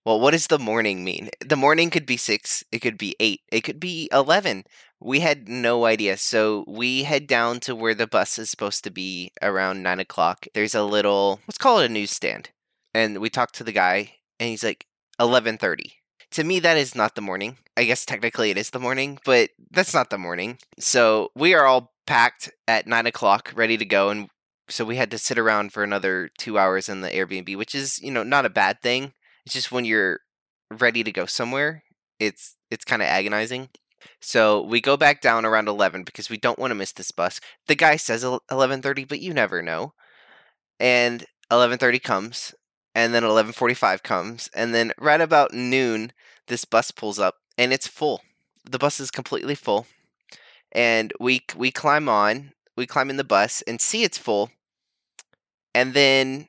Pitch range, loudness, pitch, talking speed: 105-135 Hz, -22 LUFS, 120 Hz, 195 wpm